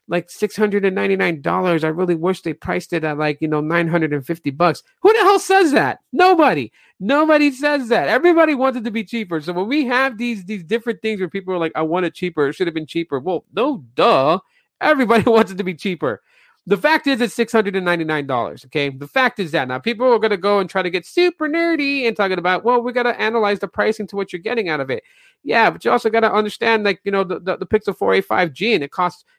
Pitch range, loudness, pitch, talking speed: 175-245 Hz, -18 LUFS, 205 Hz, 240 wpm